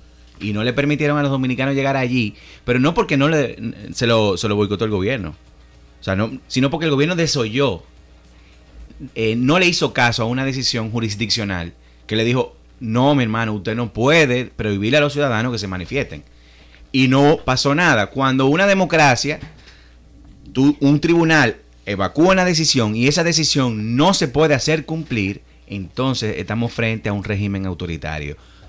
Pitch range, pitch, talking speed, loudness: 100-140 Hz, 120 Hz, 170 wpm, -18 LUFS